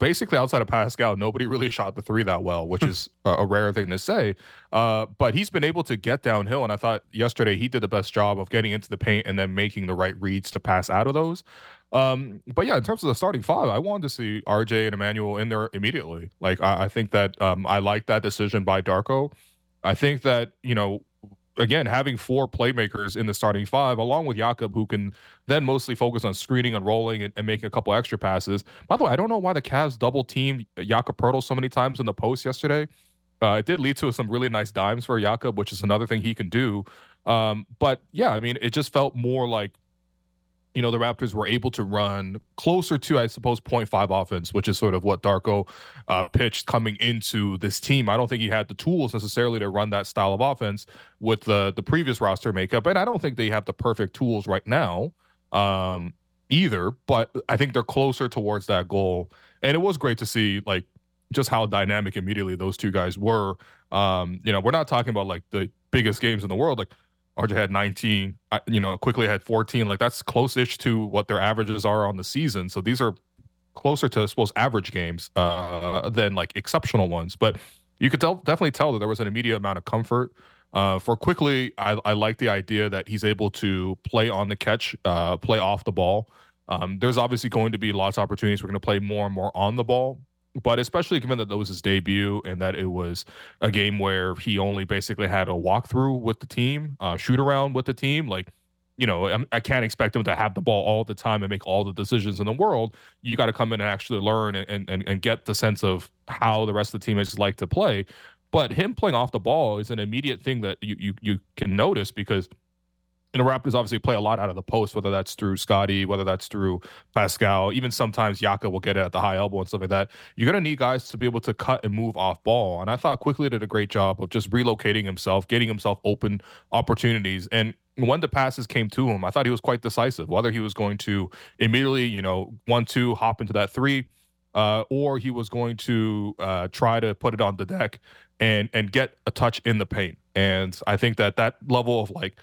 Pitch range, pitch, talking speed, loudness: 100-120 Hz, 110 Hz, 235 wpm, -24 LUFS